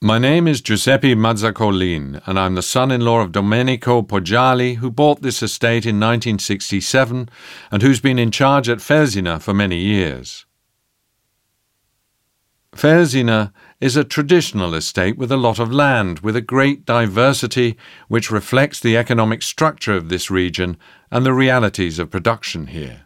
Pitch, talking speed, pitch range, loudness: 115 Hz, 145 wpm, 100-130 Hz, -16 LUFS